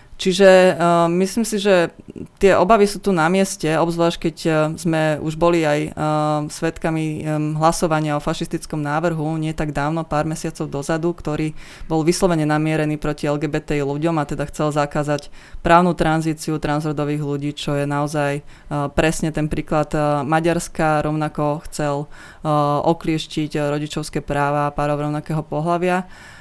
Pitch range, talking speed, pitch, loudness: 150-170 Hz, 150 wpm, 155 Hz, -19 LUFS